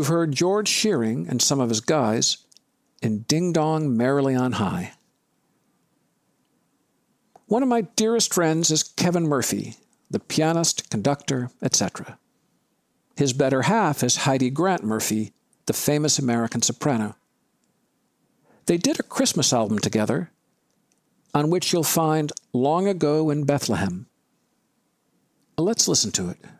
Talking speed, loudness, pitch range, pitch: 125 wpm, -22 LUFS, 120-165 Hz, 145 Hz